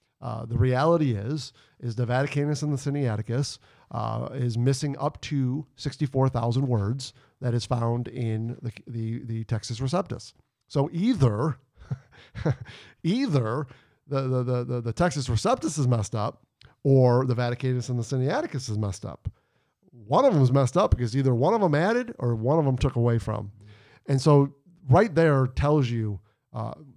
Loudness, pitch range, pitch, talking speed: -26 LUFS, 120-140 Hz, 130 Hz, 170 wpm